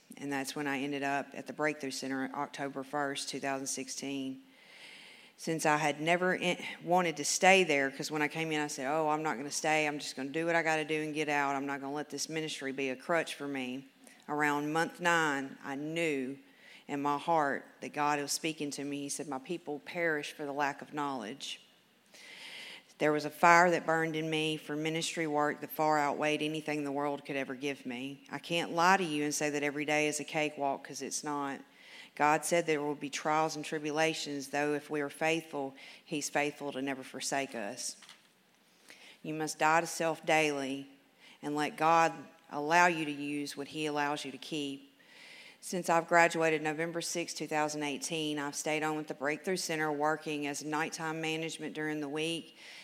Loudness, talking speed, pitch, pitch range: -33 LUFS, 205 wpm, 150 Hz, 140-160 Hz